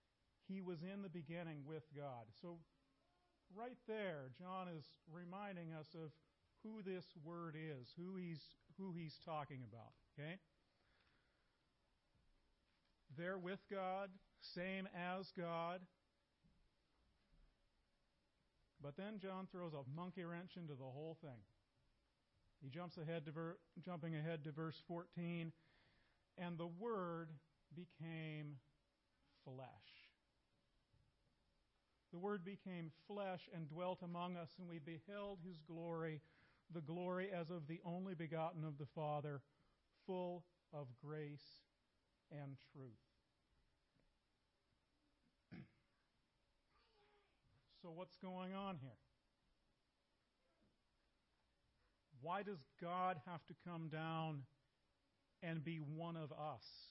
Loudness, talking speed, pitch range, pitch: -51 LUFS, 110 wpm, 150-180 Hz, 165 Hz